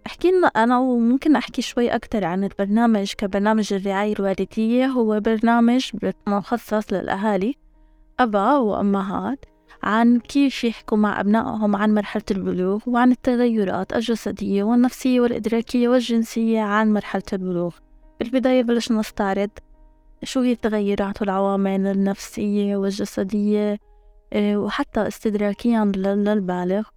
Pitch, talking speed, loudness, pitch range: 215 Hz, 100 wpm, -21 LUFS, 200-240 Hz